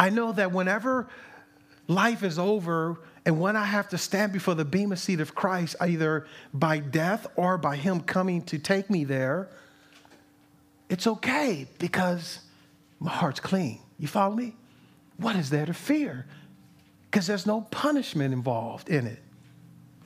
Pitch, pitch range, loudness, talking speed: 185 Hz, 160-205 Hz, -27 LUFS, 155 wpm